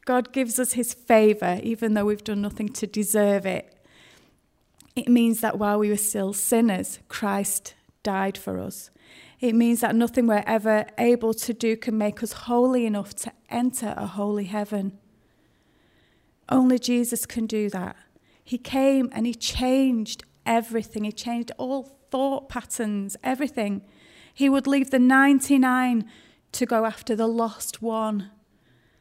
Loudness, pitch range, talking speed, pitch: -24 LUFS, 210-245 Hz, 150 wpm, 230 Hz